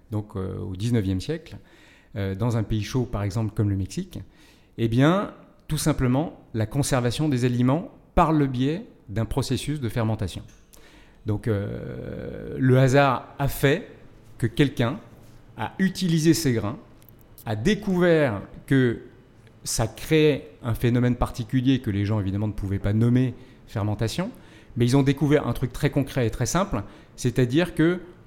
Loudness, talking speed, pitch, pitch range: -24 LUFS, 155 wpm, 120 Hz, 110-145 Hz